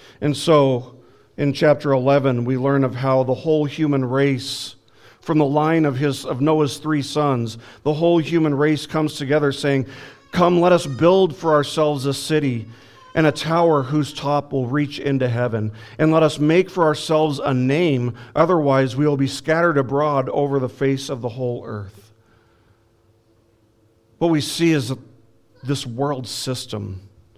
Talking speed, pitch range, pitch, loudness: 160 wpm, 125-150 Hz, 140 Hz, -19 LUFS